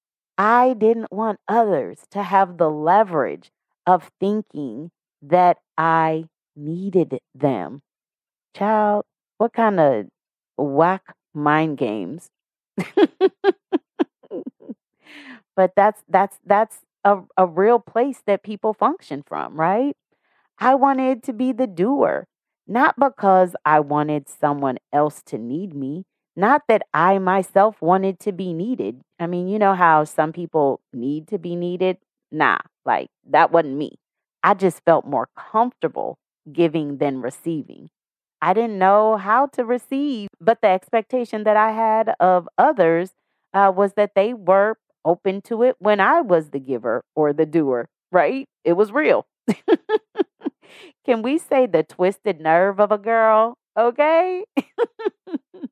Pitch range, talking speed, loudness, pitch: 170-240 Hz, 135 wpm, -20 LUFS, 200 Hz